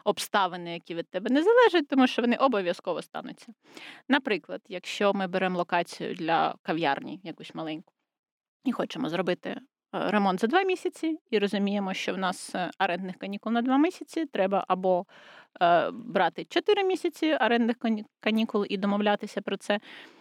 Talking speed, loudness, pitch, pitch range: 145 wpm, -27 LUFS, 220 Hz, 190-300 Hz